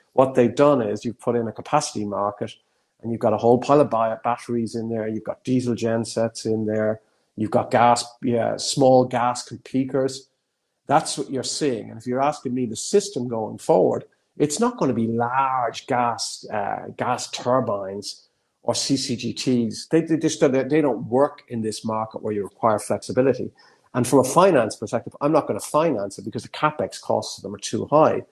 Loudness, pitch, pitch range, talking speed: -22 LUFS, 120 Hz, 115-135 Hz, 195 wpm